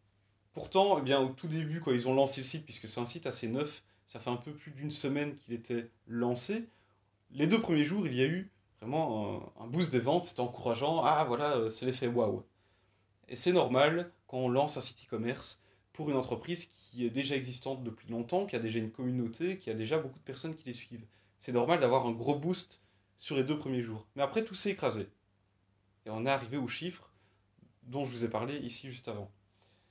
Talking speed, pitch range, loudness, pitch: 220 wpm, 110-150 Hz, -34 LUFS, 125 Hz